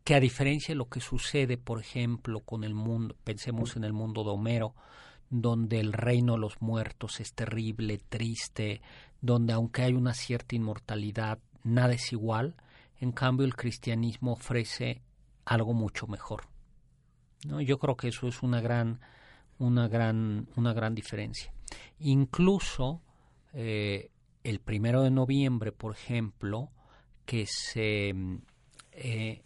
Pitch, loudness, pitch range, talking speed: 115 Hz, -31 LUFS, 110-125 Hz, 140 wpm